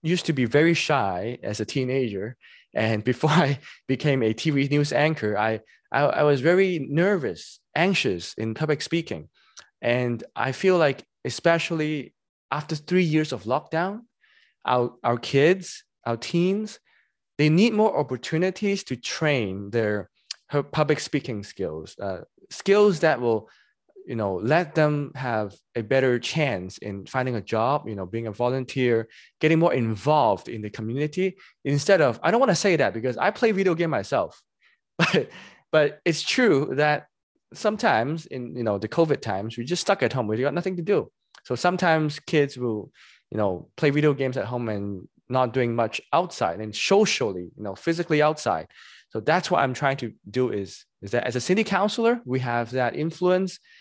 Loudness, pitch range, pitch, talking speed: -24 LUFS, 120-170 Hz, 140 Hz, 175 wpm